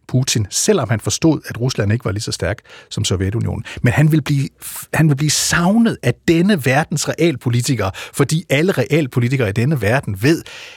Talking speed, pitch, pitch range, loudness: 180 wpm, 135 Hz, 115-160 Hz, -17 LUFS